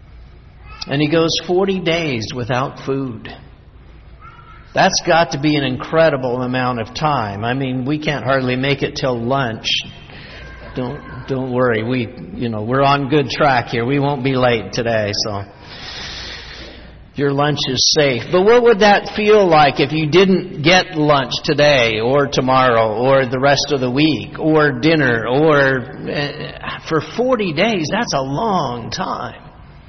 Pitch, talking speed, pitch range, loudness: 140 Hz, 155 wpm, 125-155 Hz, -16 LUFS